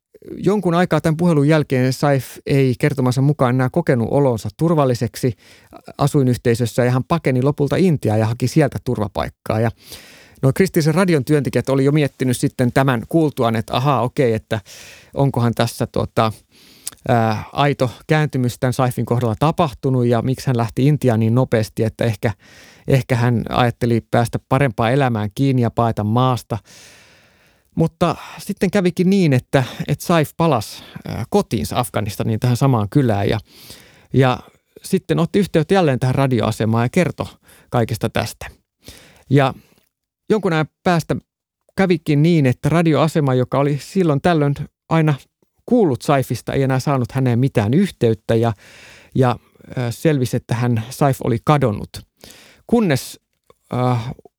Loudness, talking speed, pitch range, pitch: -18 LUFS, 135 wpm, 120-150 Hz, 130 Hz